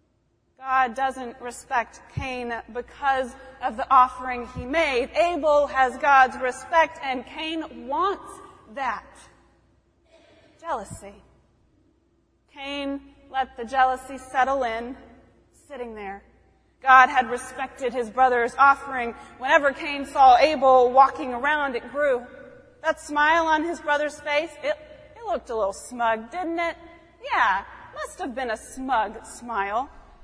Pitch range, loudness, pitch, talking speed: 250-300 Hz, -23 LUFS, 265 Hz, 125 wpm